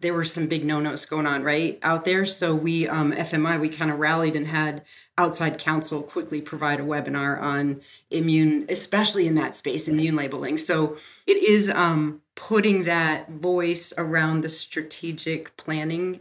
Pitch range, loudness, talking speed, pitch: 150-170 Hz, -23 LUFS, 165 wpm, 160 Hz